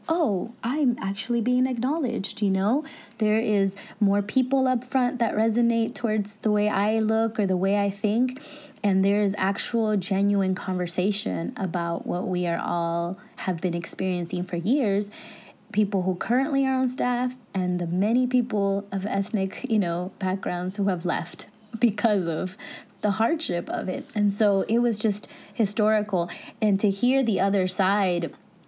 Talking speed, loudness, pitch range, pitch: 160 wpm, -25 LUFS, 190-235 Hz, 210 Hz